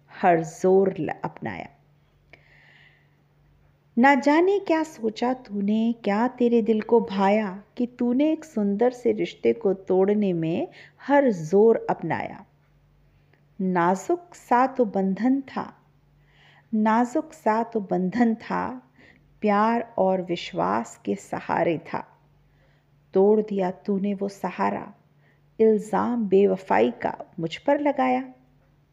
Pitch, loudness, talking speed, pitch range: 200 Hz, -24 LUFS, 110 wpm, 170-240 Hz